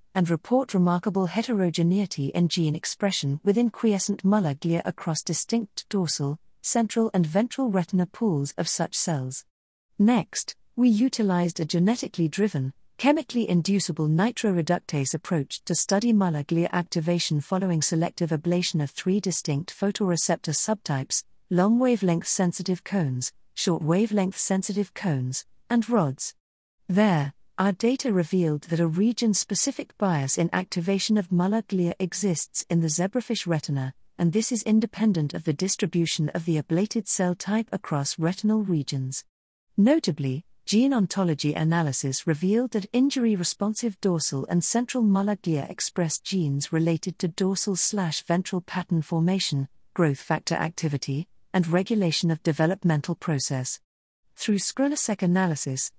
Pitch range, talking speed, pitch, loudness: 160-205 Hz, 130 wpm, 180 Hz, -25 LUFS